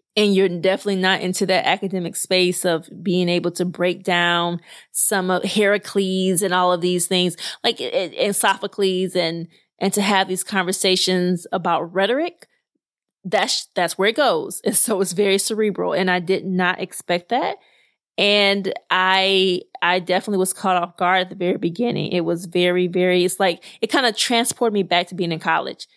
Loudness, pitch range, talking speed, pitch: -19 LUFS, 180-195 Hz, 180 wpm, 185 Hz